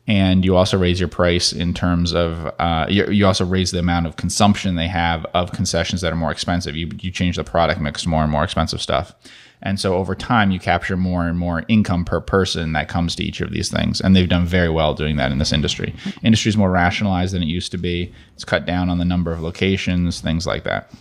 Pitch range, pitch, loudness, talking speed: 85-95 Hz, 90 Hz, -19 LUFS, 245 wpm